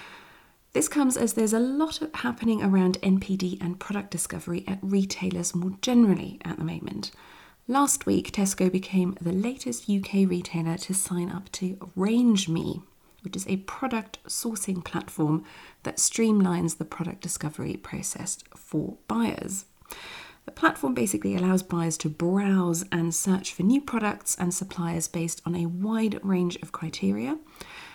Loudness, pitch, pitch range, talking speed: -27 LUFS, 190 Hz, 175-220 Hz, 145 wpm